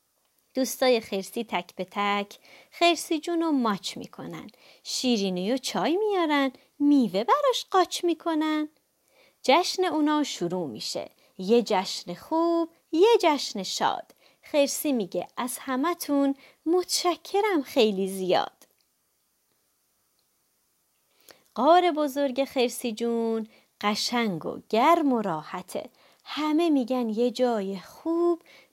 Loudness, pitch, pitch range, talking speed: -26 LUFS, 270 Hz, 220-330 Hz, 100 wpm